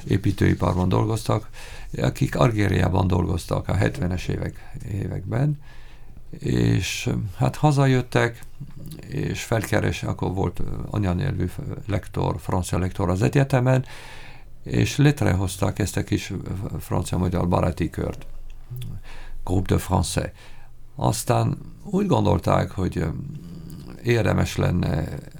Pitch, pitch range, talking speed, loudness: 105 Hz, 90-130 Hz, 90 wpm, -24 LUFS